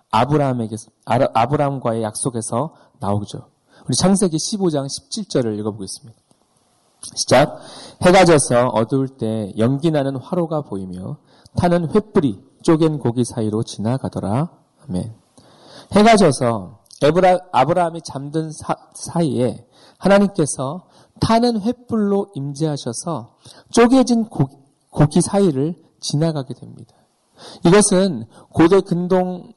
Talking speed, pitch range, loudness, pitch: 255 characters per minute, 120-180 Hz, -18 LUFS, 145 Hz